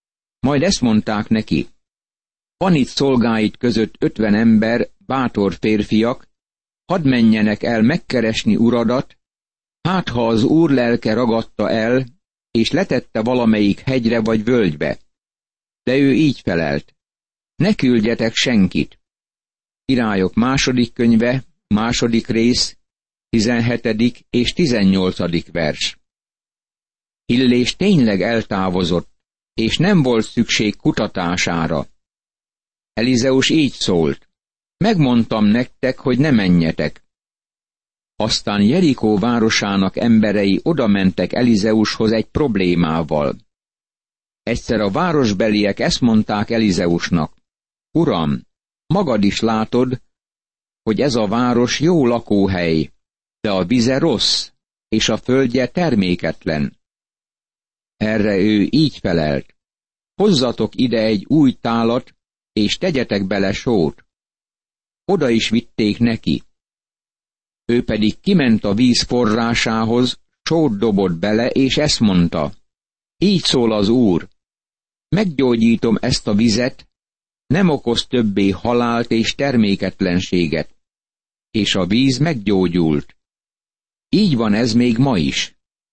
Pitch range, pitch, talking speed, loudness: 105-125 Hz, 115 Hz, 105 wpm, -17 LUFS